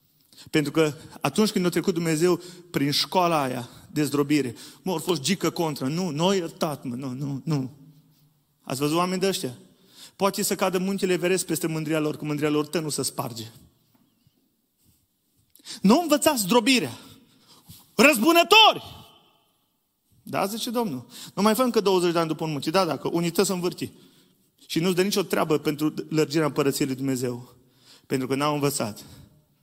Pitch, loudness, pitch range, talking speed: 160 Hz, -24 LUFS, 145-185 Hz, 165 wpm